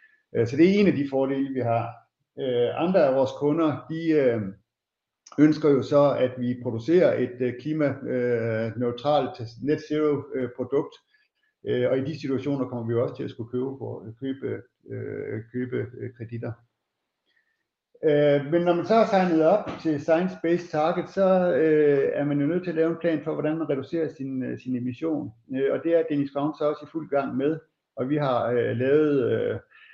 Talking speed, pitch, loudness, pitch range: 165 wpm, 145 Hz, -25 LUFS, 125-160 Hz